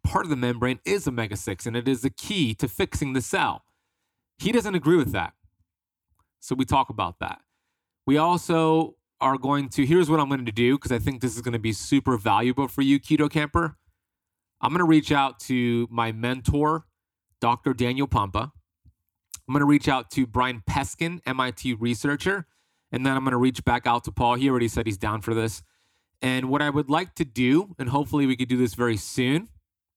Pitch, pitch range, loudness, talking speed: 130 Hz, 115-145 Hz, -24 LUFS, 210 wpm